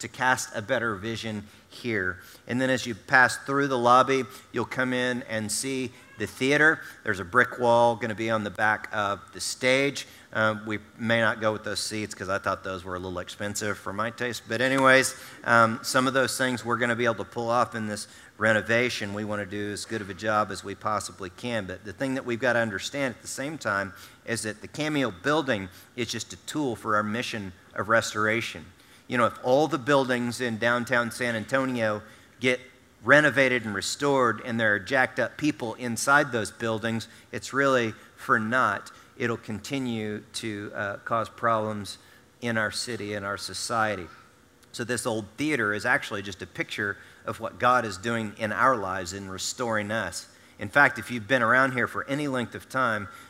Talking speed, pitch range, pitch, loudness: 205 wpm, 105-125 Hz, 115 Hz, -26 LUFS